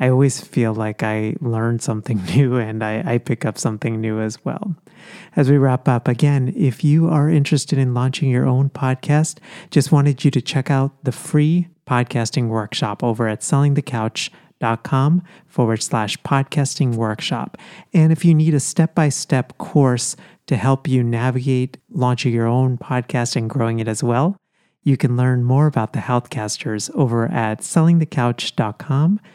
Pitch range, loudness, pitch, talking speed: 120-150 Hz, -19 LUFS, 135 Hz, 165 wpm